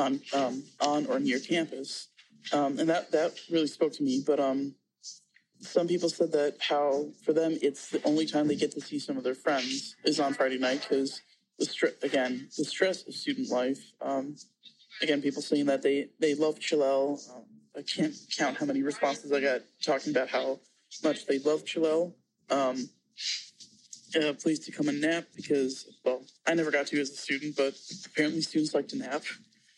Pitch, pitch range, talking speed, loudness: 145 Hz, 135-160 Hz, 195 wpm, -30 LUFS